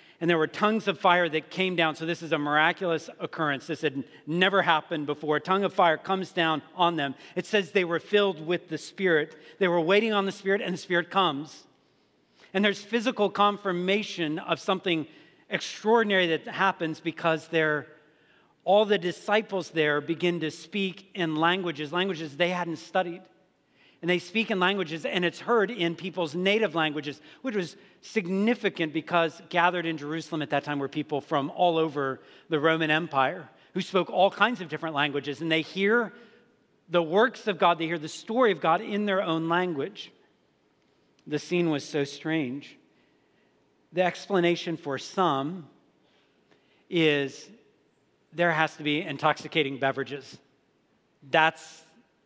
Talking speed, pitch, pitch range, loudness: 160 wpm, 170 Hz, 155-190 Hz, -27 LUFS